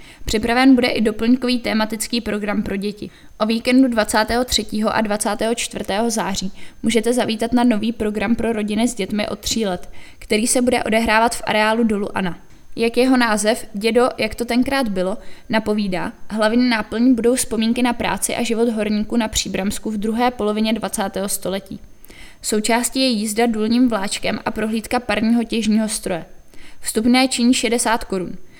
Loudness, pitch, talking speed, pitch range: -19 LUFS, 225 Hz, 155 wpm, 210-240 Hz